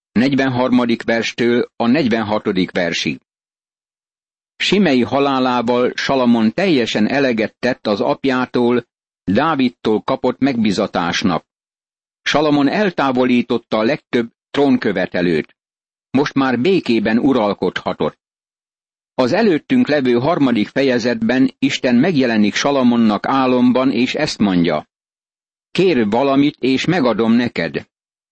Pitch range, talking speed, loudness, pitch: 120-140 Hz, 90 wpm, -16 LUFS, 125 Hz